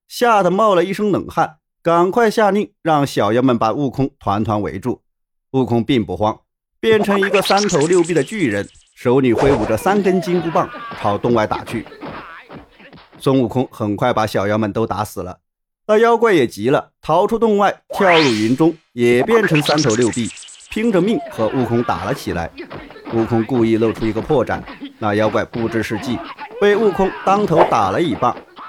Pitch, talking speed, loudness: 135 Hz, 260 characters per minute, -17 LUFS